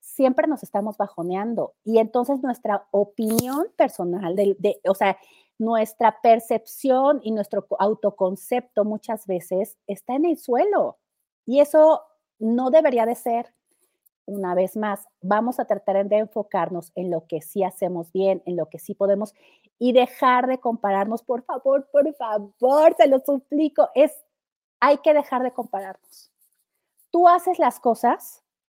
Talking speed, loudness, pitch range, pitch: 145 wpm, -22 LUFS, 200-270 Hz, 225 Hz